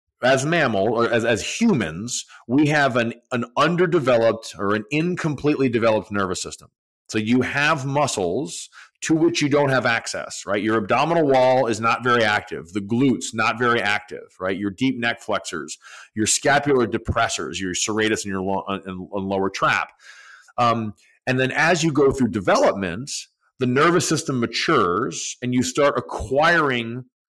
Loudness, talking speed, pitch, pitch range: -21 LUFS, 160 wpm, 120 Hz, 110-140 Hz